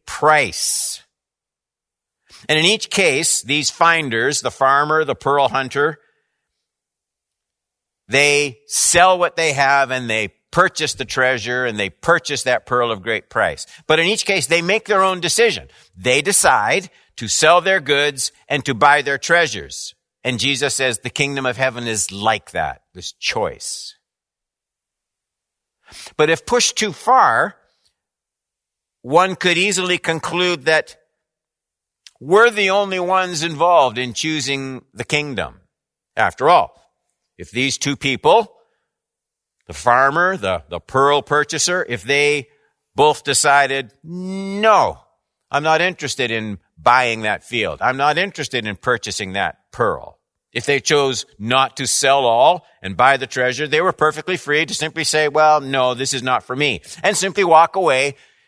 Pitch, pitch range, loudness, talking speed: 145 Hz, 130-170 Hz, -16 LUFS, 145 wpm